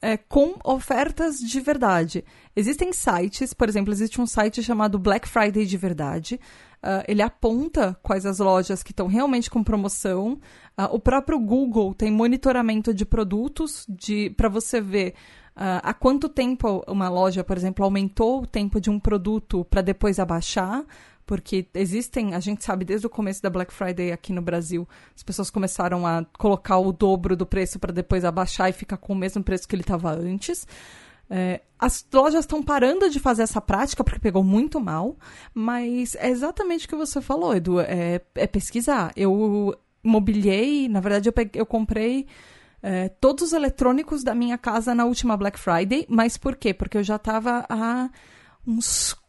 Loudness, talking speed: -23 LUFS, 175 wpm